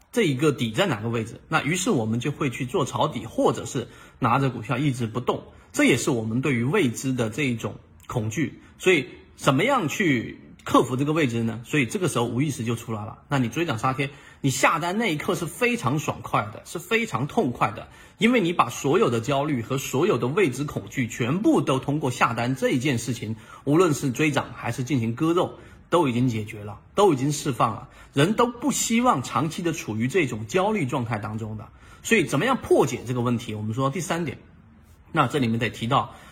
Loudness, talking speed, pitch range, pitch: -24 LUFS, 315 characters per minute, 115-150 Hz, 130 Hz